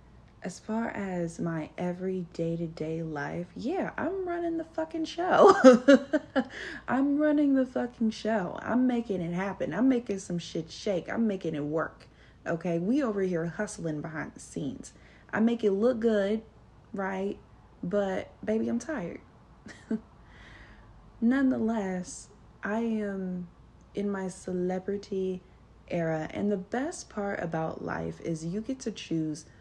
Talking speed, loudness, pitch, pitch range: 135 wpm, -29 LUFS, 200 Hz, 170-235 Hz